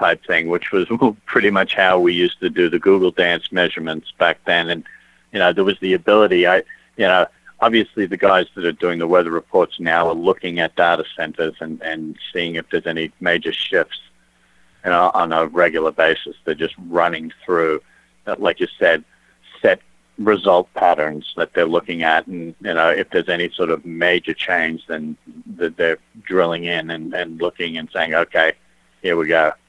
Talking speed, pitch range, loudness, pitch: 190 wpm, 80-95 Hz, -18 LUFS, 85 Hz